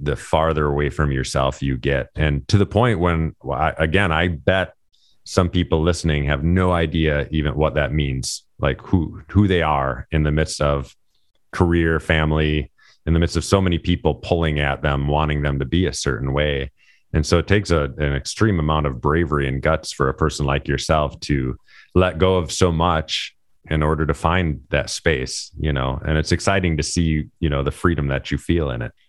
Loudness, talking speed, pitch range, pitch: -20 LUFS, 200 wpm, 70-85 Hz, 75 Hz